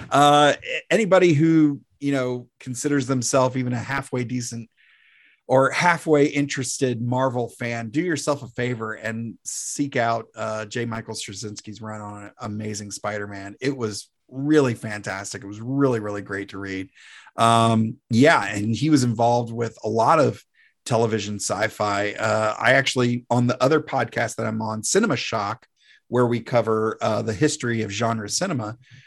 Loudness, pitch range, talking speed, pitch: -22 LUFS, 110-135 Hz, 160 wpm, 120 Hz